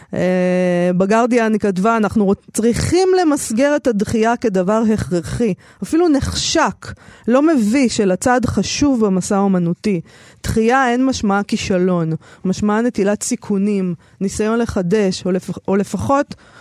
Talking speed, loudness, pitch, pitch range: 115 wpm, -17 LUFS, 210 Hz, 185-235 Hz